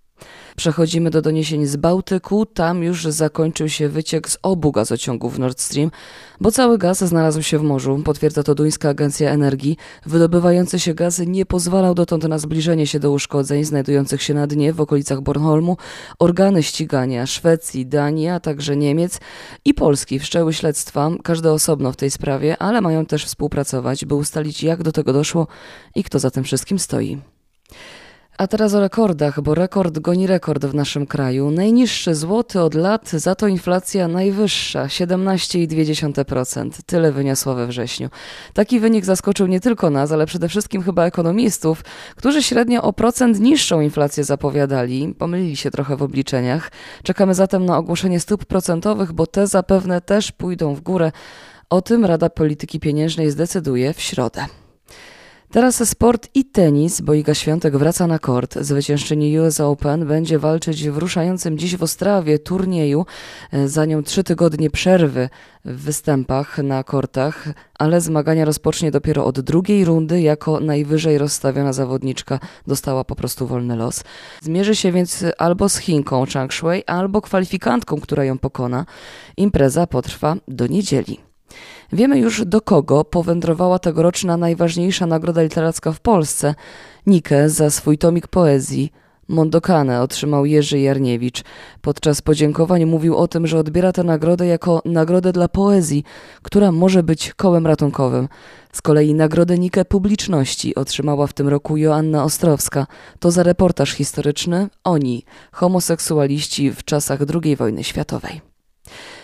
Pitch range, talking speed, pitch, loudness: 145-180 Hz, 145 wpm, 160 Hz, -17 LUFS